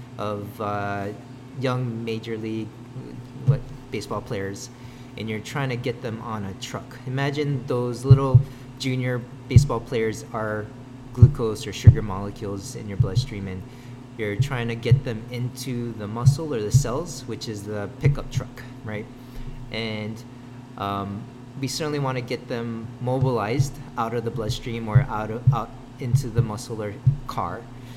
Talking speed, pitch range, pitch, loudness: 150 wpm, 110-130 Hz, 125 Hz, -25 LUFS